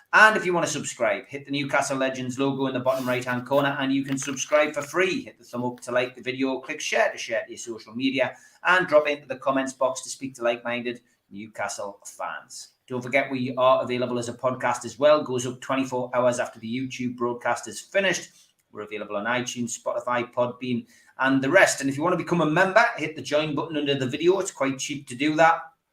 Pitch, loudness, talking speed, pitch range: 135 Hz, -25 LUFS, 235 wpm, 125-150 Hz